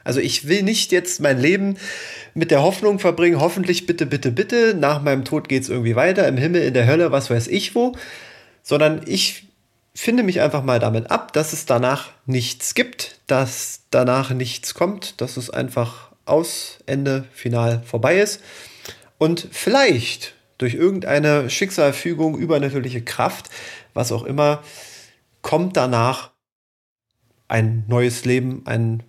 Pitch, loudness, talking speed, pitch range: 140 Hz, -19 LUFS, 150 wpm, 125-175 Hz